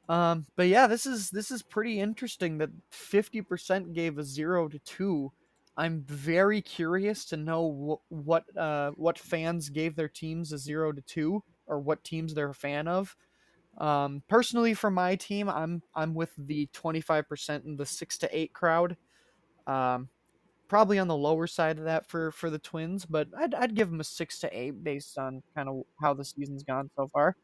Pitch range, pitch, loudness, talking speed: 150-185 Hz, 165 Hz, -30 LUFS, 200 wpm